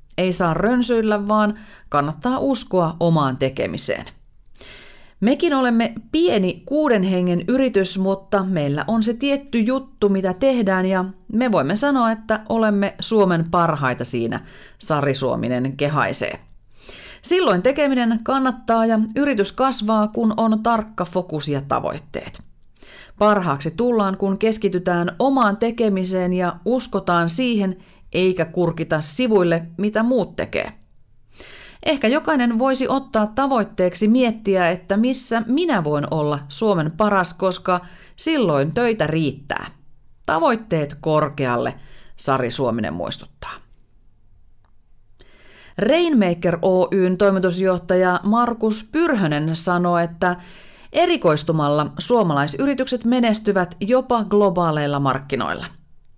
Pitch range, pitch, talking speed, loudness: 175-235 Hz, 200 Hz, 100 wpm, -19 LUFS